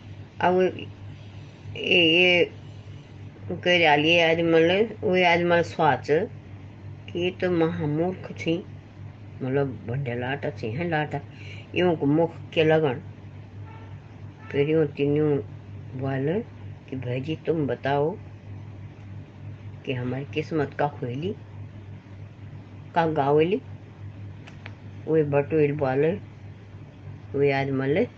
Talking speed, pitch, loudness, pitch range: 85 wpm, 125 Hz, -24 LUFS, 105-150 Hz